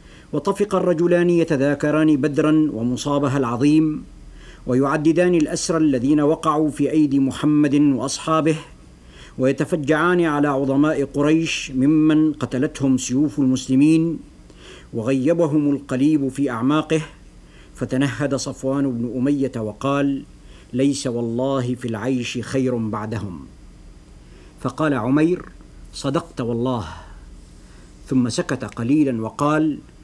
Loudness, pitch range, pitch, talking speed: -20 LUFS, 120-155 Hz, 140 Hz, 90 wpm